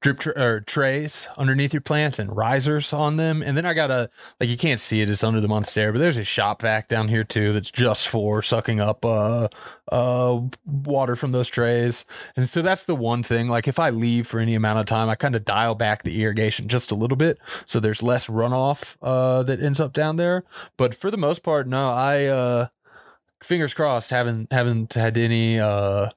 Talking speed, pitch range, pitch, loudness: 220 wpm, 110-145 Hz, 125 Hz, -22 LUFS